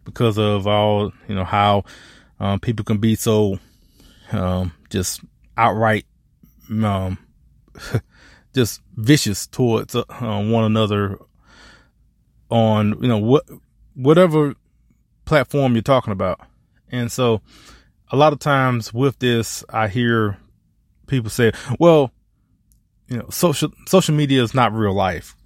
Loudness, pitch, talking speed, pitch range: -19 LUFS, 110 Hz, 125 wpm, 100-125 Hz